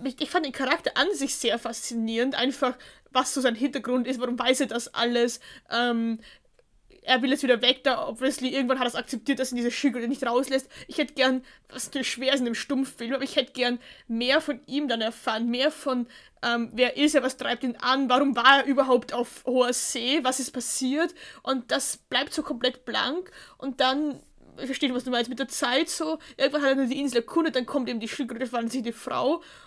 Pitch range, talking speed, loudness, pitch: 245-275 Hz, 220 wpm, -26 LUFS, 260 Hz